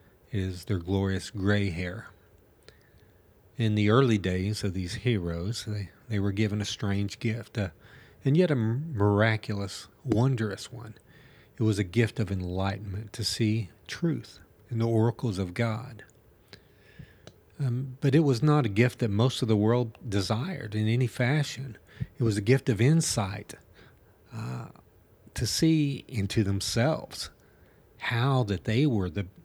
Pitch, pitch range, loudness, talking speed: 110 Hz, 100-125 Hz, -28 LUFS, 145 wpm